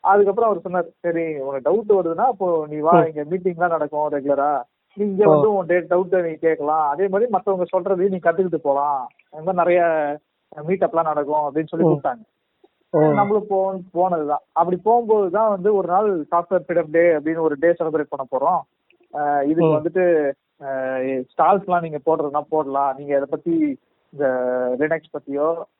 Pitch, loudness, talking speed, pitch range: 165 Hz, -20 LUFS, 130 wpm, 150-190 Hz